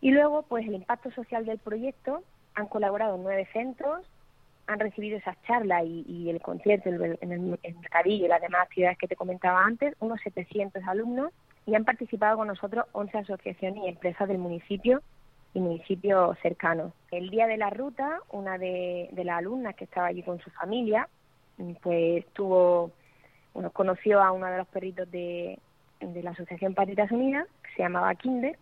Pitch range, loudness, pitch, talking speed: 175-220 Hz, -29 LUFS, 195 Hz, 180 wpm